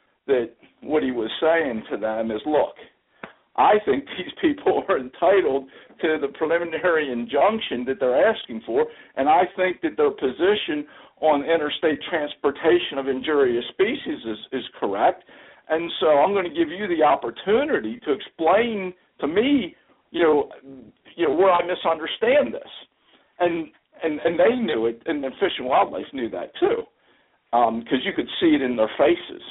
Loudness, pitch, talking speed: -22 LUFS, 170 Hz, 165 wpm